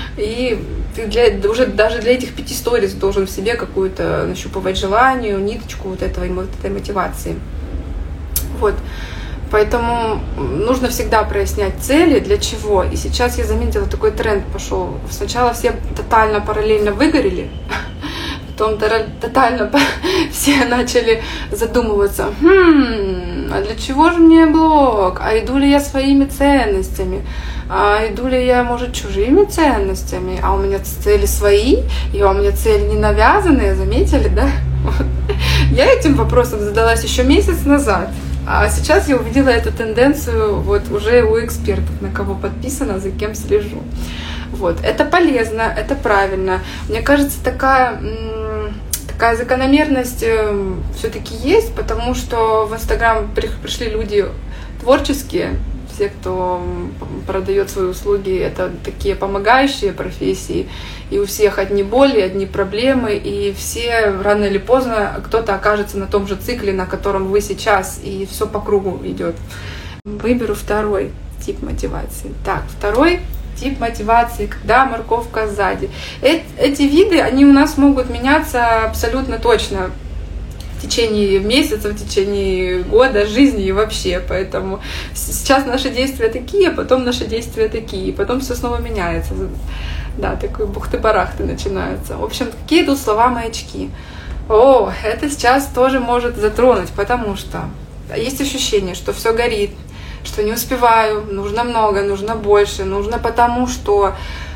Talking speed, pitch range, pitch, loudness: 135 wpm, 195-260 Hz, 220 Hz, -16 LUFS